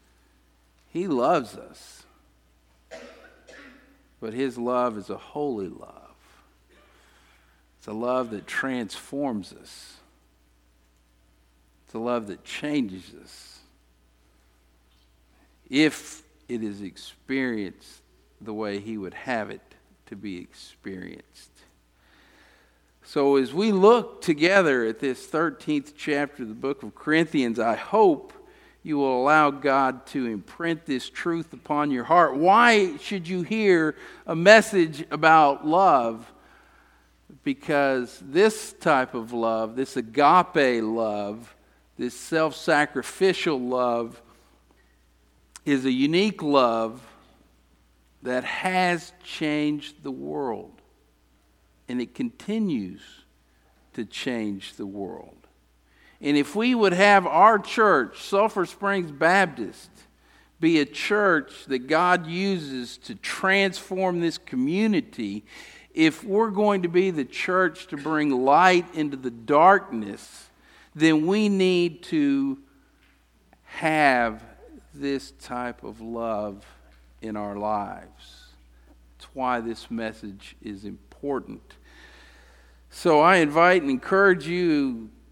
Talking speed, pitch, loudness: 110 wpm, 130 Hz, -23 LUFS